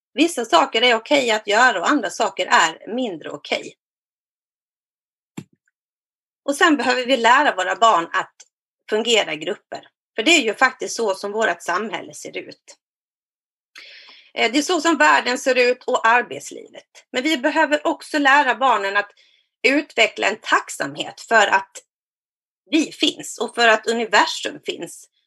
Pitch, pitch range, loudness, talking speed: 250 Hz, 225-305 Hz, -18 LUFS, 150 wpm